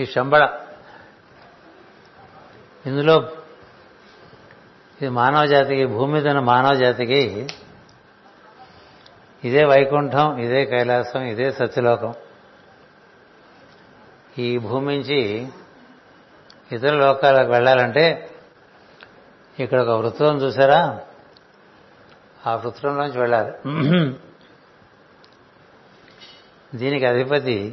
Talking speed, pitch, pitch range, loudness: 65 wpm, 135 Hz, 125-145 Hz, -19 LUFS